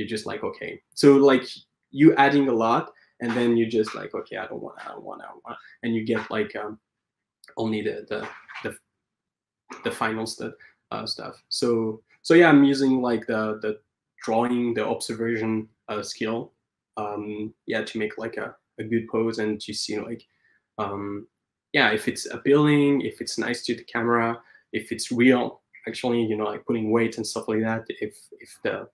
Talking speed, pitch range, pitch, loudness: 190 wpm, 110-120 Hz, 115 Hz, -24 LUFS